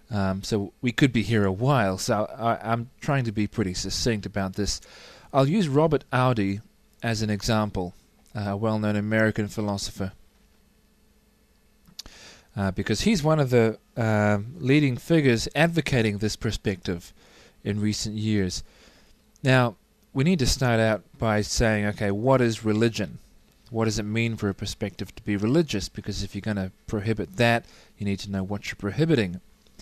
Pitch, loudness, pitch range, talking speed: 110 Hz, -25 LUFS, 100-120 Hz, 165 wpm